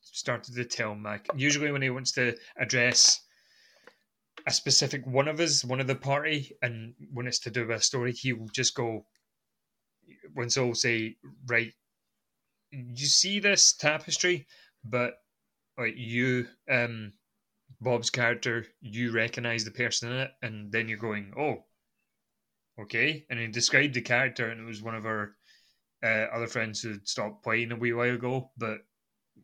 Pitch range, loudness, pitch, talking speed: 115-135 Hz, -27 LUFS, 120 Hz, 165 wpm